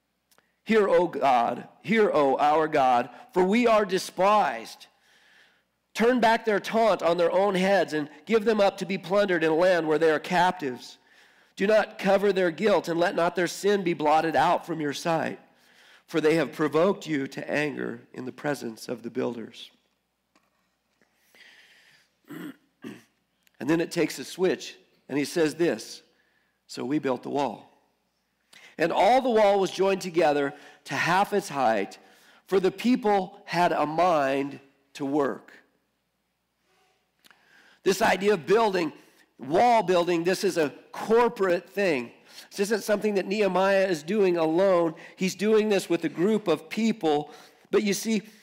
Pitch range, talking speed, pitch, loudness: 155-205 Hz, 155 wpm, 180 Hz, -25 LUFS